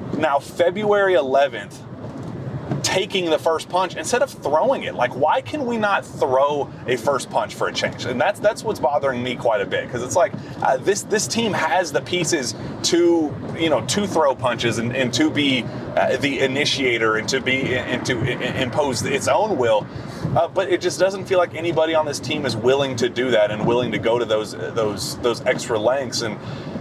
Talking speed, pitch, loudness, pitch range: 205 wpm, 145 Hz, -20 LUFS, 125-175 Hz